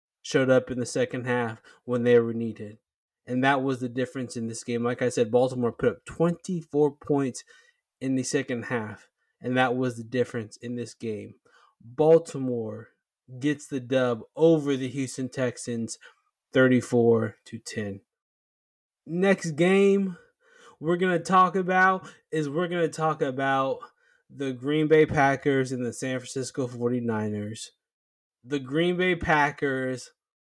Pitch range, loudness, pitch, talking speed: 120-160 Hz, -26 LUFS, 130 Hz, 150 wpm